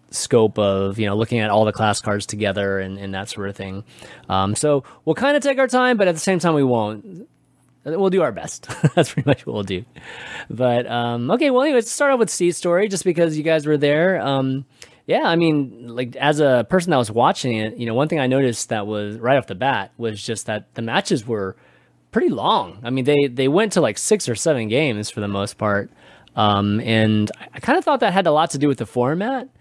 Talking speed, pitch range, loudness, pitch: 245 wpm, 105-160 Hz, -19 LUFS, 125 Hz